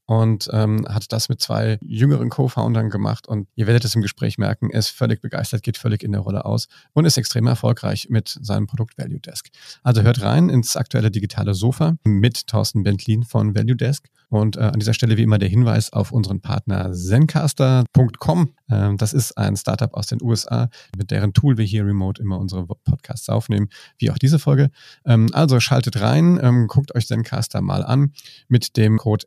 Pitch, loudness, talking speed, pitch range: 115 Hz, -19 LUFS, 195 wpm, 110-130 Hz